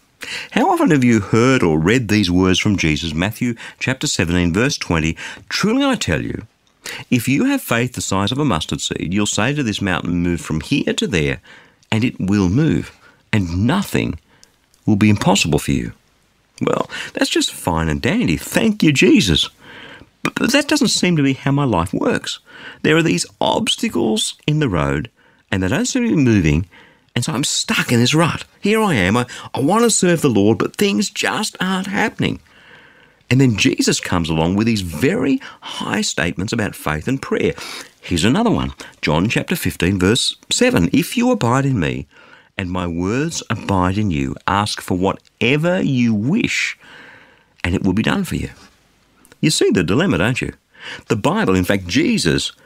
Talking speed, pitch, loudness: 185 wpm, 115 Hz, -17 LUFS